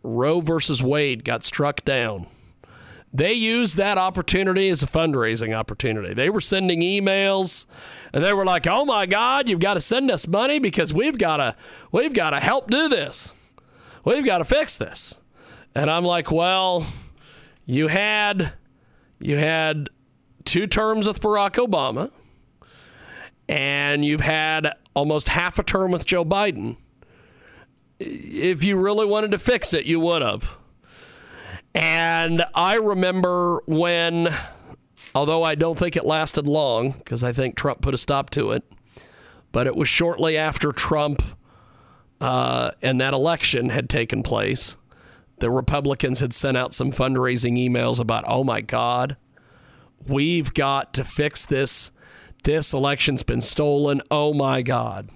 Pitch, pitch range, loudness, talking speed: 155 Hz, 135-185 Hz, -21 LUFS, 150 wpm